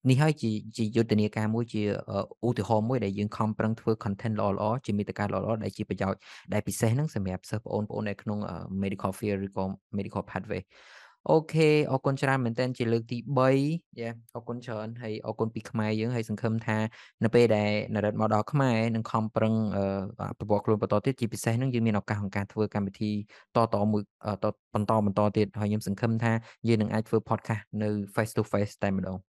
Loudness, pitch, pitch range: -29 LUFS, 110 Hz, 105-115 Hz